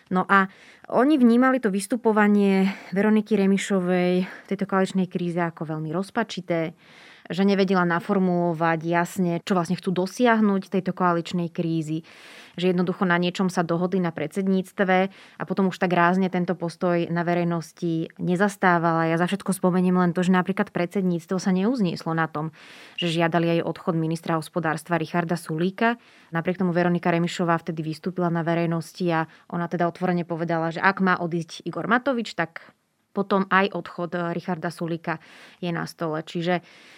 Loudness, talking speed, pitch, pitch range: -24 LUFS, 155 wpm, 180 Hz, 170-190 Hz